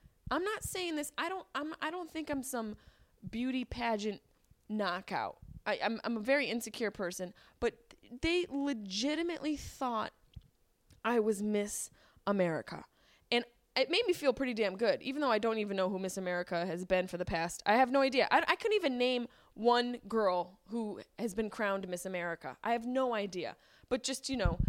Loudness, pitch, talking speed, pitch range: -34 LUFS, 235 Hz, 190 wpm, 200-270 Hz